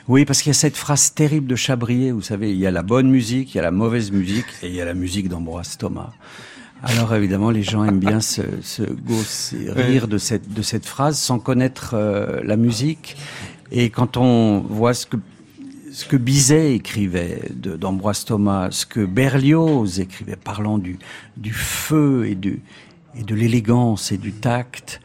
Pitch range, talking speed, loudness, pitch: 100-130 Hz, 195 wpm, -19 LUFS, 115 Hz